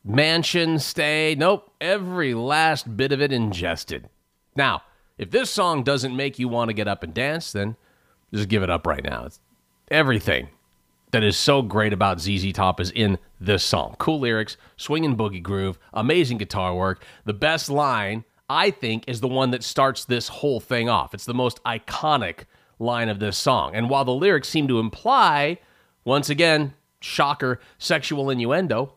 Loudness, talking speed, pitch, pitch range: -22 LUFS, 175 wpm, 120 Hz, 100-145 Hz